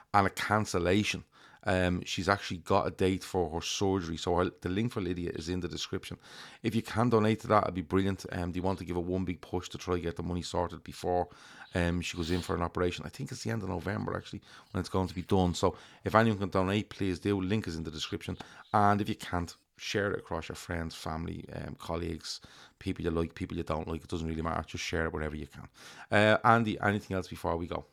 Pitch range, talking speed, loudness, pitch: 85-100 Hz, 255 wpm, -32 LUFS, 90 Hz